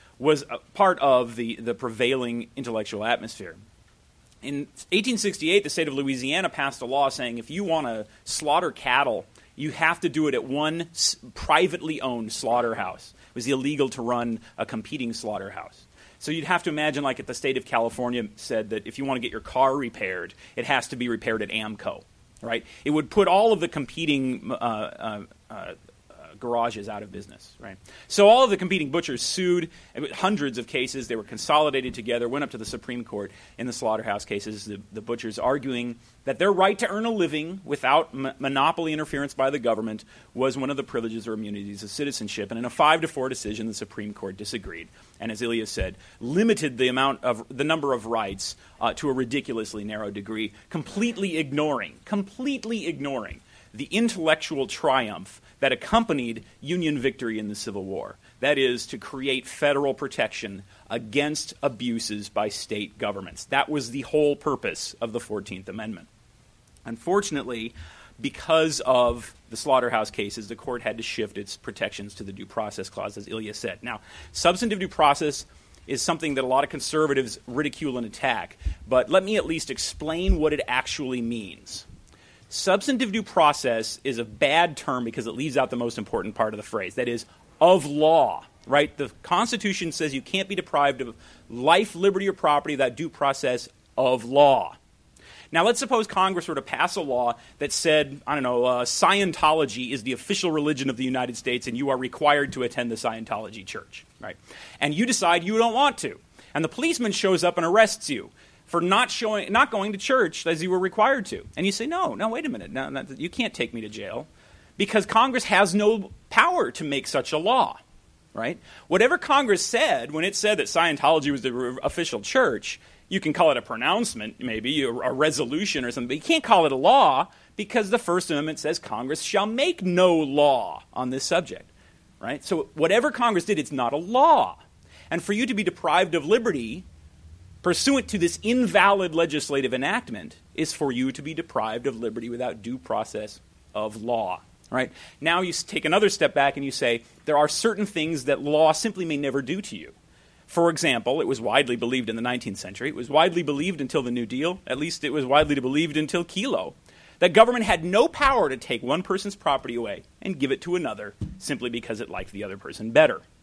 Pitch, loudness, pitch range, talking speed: 140 Hz, -24 LUFS, 120-175 Hz, 195 wpm